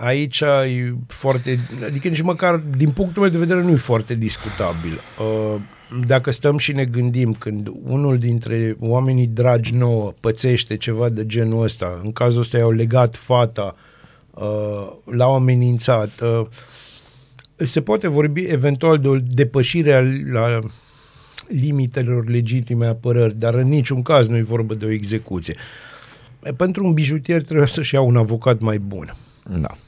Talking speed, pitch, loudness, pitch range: 145 wpm, 125 Hz, -18 LUFS, 115-140 Hz